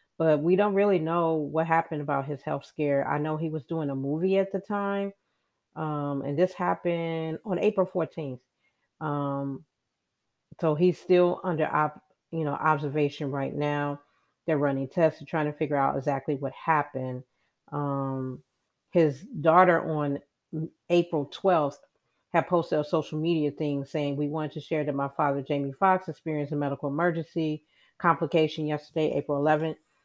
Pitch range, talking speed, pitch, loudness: 145-165 Hz, 160 wpm, 155 Hz, -28 LUFS